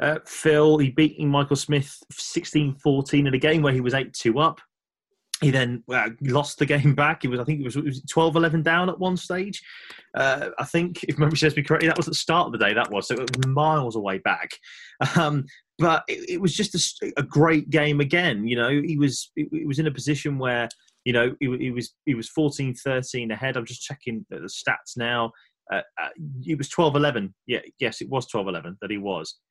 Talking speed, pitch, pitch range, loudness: 220 wpm, 145 Hz, 125-155 Hz, -23 LUFS